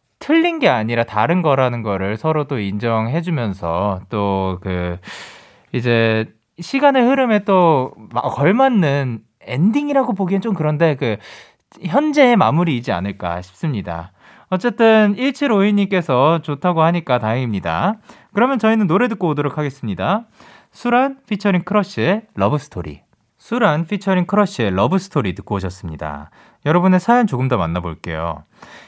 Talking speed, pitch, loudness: 310 characters per minute, 155 Hz, -17 LUFS